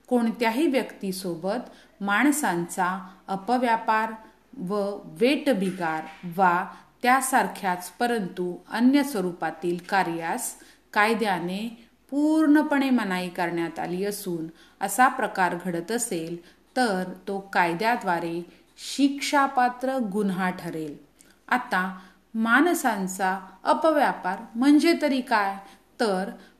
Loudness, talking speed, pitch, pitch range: -25 LUFS, 80 wpm, 200 Hz, 180-250 Hz